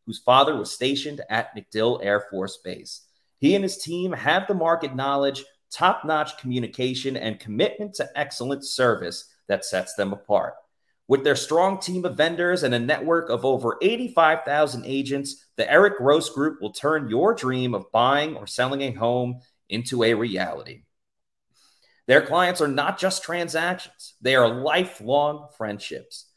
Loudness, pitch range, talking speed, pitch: -23 LUFS, 125-165 Hz, 155 wpm, 140 Hz